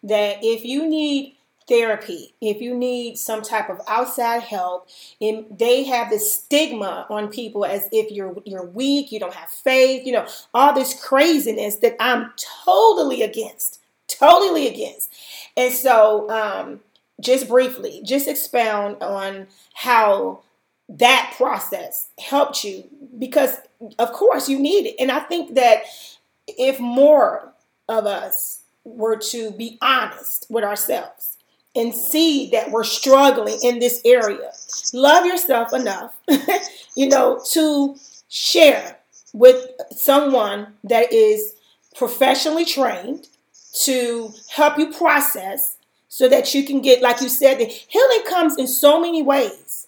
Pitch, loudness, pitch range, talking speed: 265 Hz, -18 LUFS, 230-300 Hz, 135 wpm